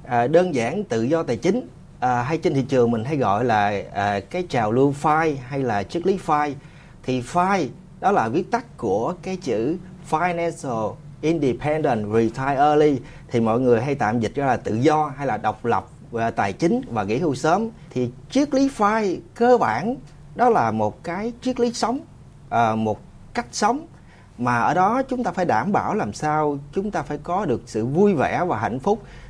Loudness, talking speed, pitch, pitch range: -22 LUFS, 200 wpm, 155 Hz, 120-185 Hz